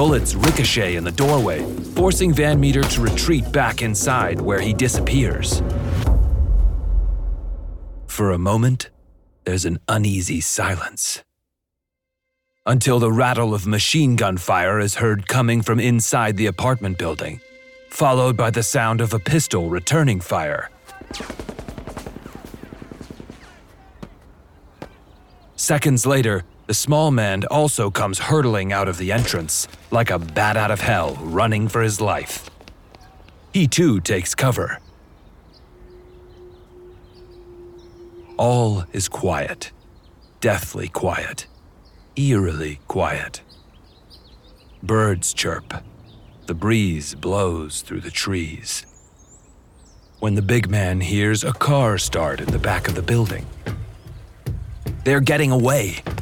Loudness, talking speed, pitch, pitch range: -20 LUFS, 110 wpm, 105 Hz, 90-120 Hz